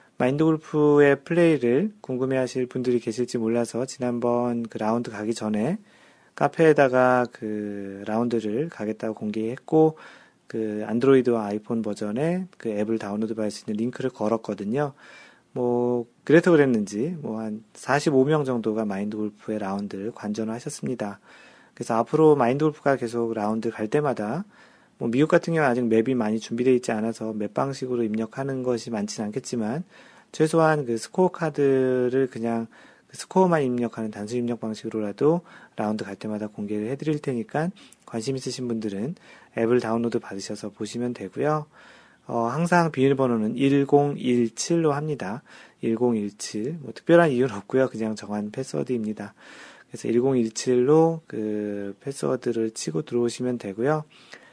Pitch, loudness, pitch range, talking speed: 120 Hz, -25 LUFS, 110-140 Hz, 335 characters per minute